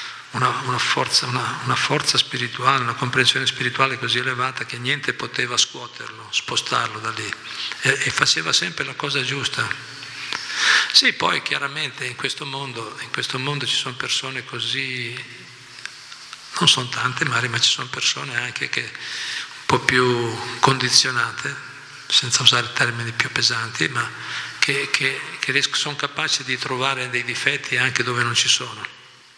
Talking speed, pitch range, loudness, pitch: 150 wpm, 120-135 Hz, -20 LUFS, 125 Hz